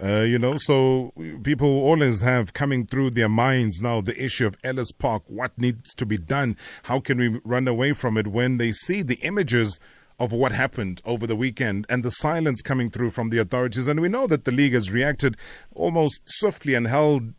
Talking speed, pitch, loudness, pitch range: 205 wpm, 125 Hz, -23 LUFS, 115-140 Hz